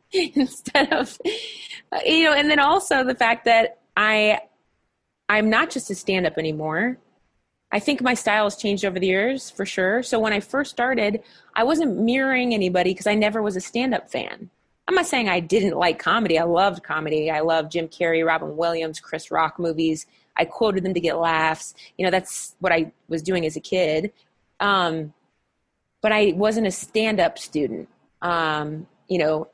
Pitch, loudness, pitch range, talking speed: 205 Hz, -22 LUFS, 170-240 Hz, 180 wpm